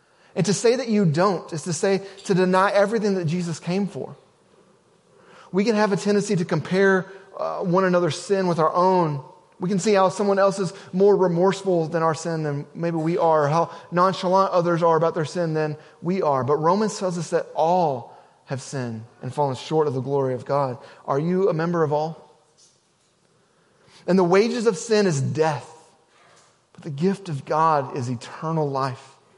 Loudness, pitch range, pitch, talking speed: -22 LUFS, 155-195 Hz, 175 Hz, 190 wpm